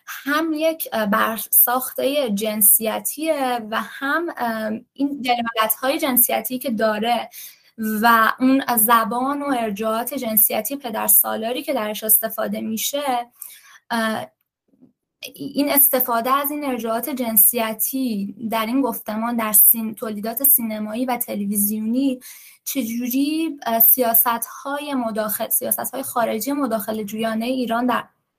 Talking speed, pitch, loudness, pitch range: 105 wpm, 235 Hz, -19 LUFS, 220-265 Hz